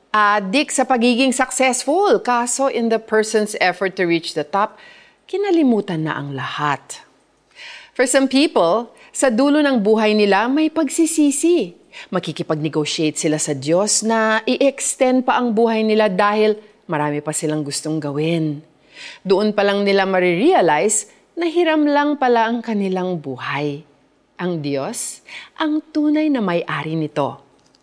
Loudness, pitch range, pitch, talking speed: -18 LUFS, 165-265 Hz, 215 Hz, 135 wpm